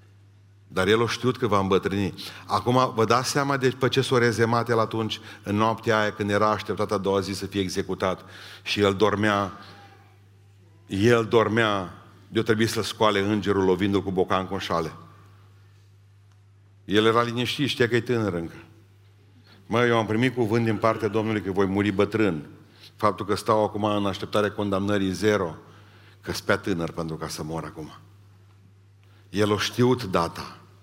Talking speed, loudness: 170 wpm, -24 LUFS